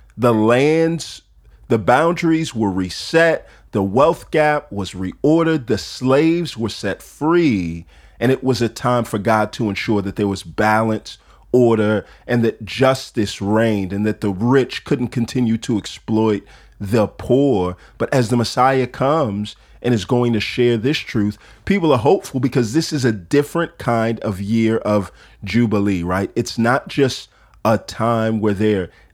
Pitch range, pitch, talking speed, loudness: 105-130 Hz, 115 Hz, 160 wpm, -18 LUFS